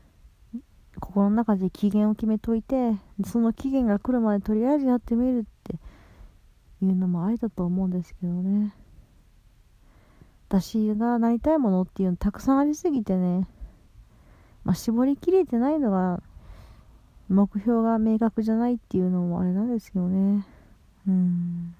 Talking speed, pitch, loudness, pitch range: 290 characters per minute, 210 Hz, -25 LUFS, 185-235 Hz